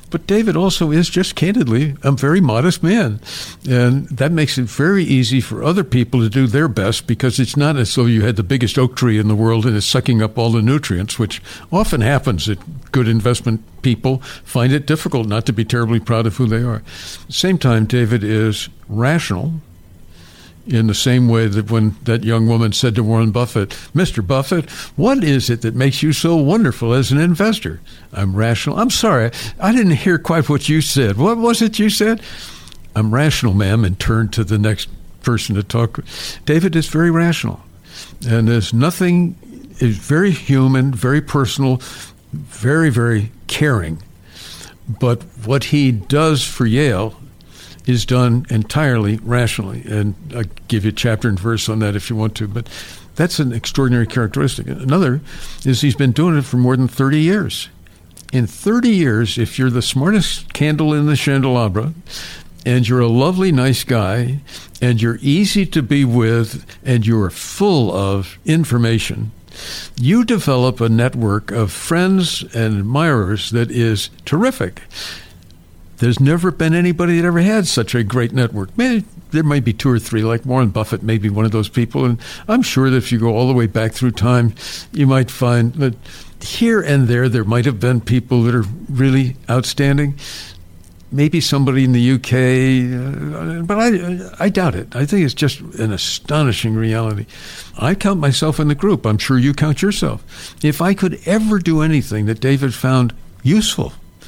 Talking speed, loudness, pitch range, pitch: 180 wpm, -16 LUFS, 110-150 Hz, 125 Hz